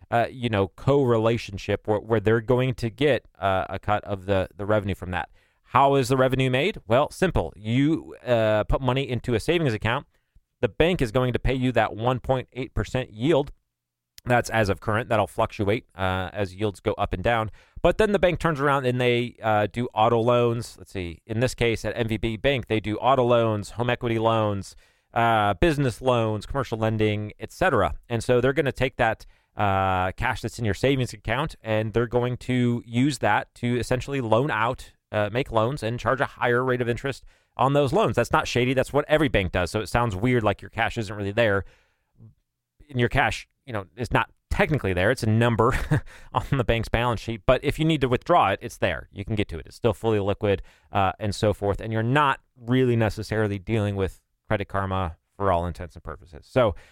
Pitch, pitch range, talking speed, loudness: 115 Hz, 105-125 Hz, 210 wpm, -24 LUFS